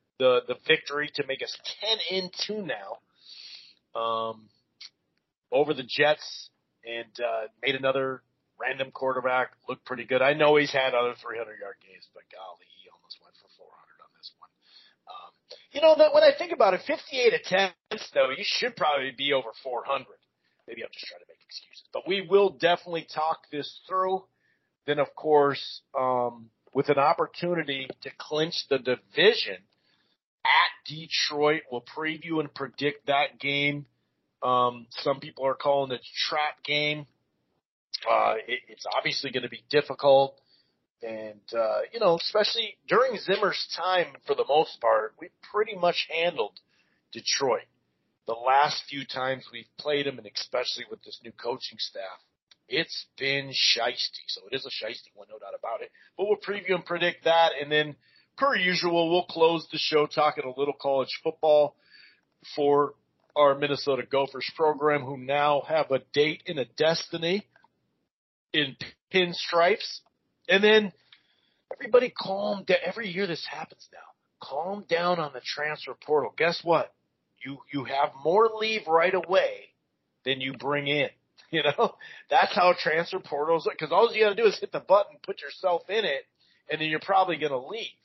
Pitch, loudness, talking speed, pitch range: 155 Hz, -26 LUFS, 170 wpm, 140-195 Hz